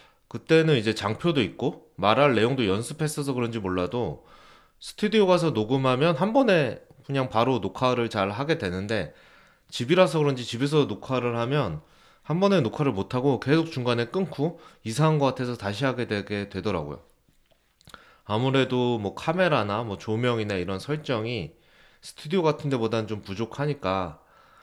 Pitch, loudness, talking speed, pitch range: 125 Hz, -25 LUFS, 330 characters per minute, 110-150 Hz